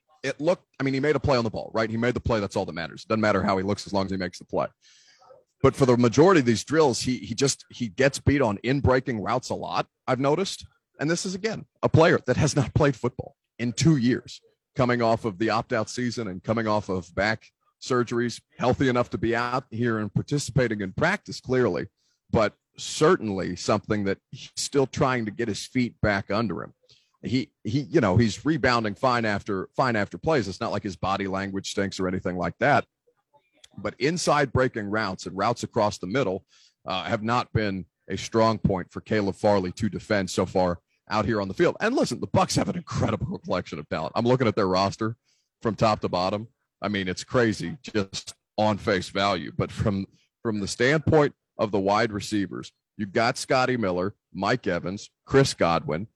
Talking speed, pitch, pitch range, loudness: 210 wpm, 115 Hz, 100-130 Hz, -25 LUFS